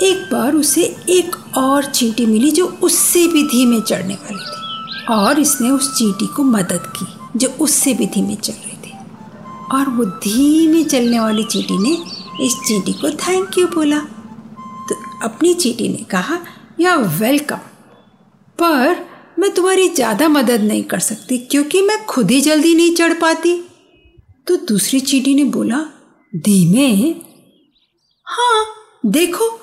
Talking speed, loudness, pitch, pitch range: 145 wpm, -15 LUFS, 270 Hz, 220-330 Hz